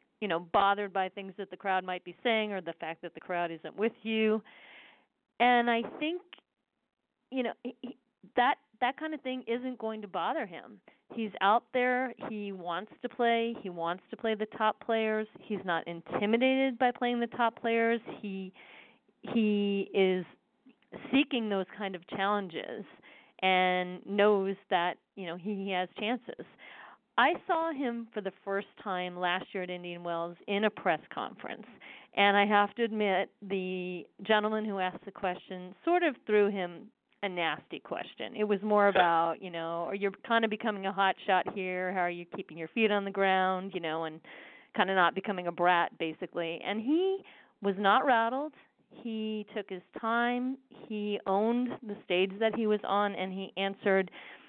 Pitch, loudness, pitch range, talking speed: 205 Hz, -31 LUFS, 185-230 Hz, 180 wpm